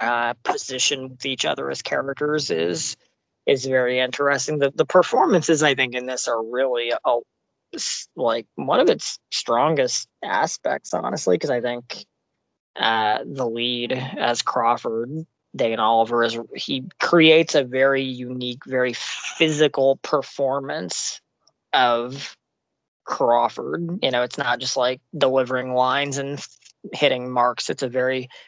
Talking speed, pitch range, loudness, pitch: 135 wpm, 120-140 Hz, -21 LUFS, 130 Hz